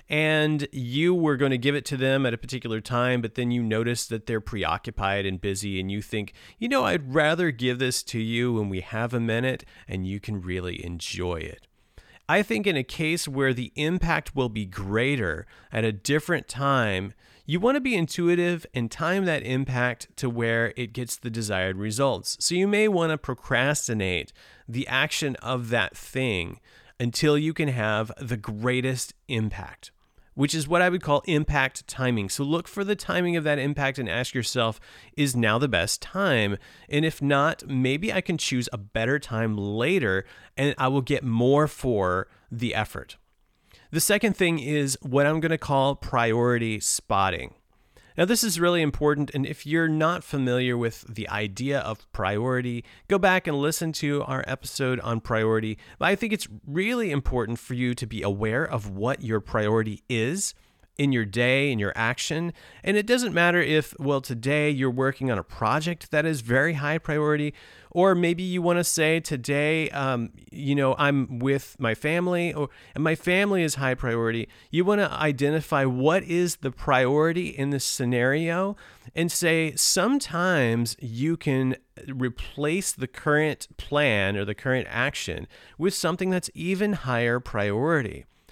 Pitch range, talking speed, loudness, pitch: 115-155 Hz, 175 wpm, -25 LUFS, 135 Hz